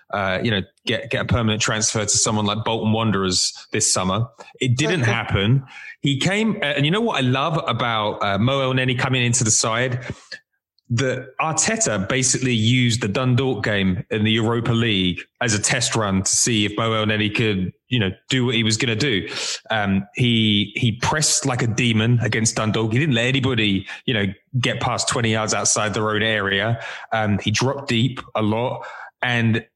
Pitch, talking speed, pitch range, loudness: 115 Hz, 190 wpm, 110-130 Hz, -20 LUFS